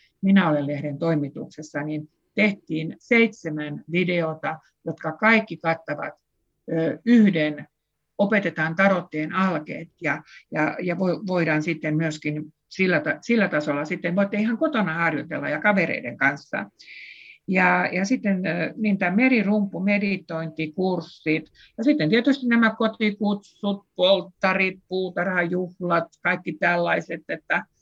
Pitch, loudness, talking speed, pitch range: 180 Hz, -23 LUFS, 110 wpm, 160-200 Hz